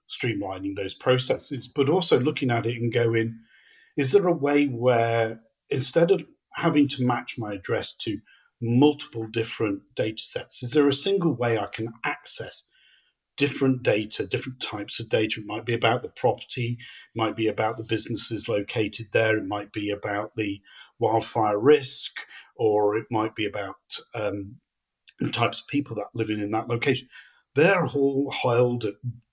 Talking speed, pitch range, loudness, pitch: 165 wpm, 110-135 Hz, -25 LUFS, 115 Hz